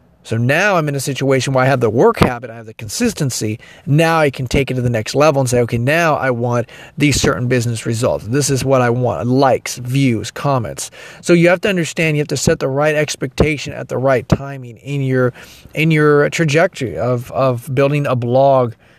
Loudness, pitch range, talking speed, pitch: -15 LUFS, 125-150 Hz, 220 wpm, 135 Hz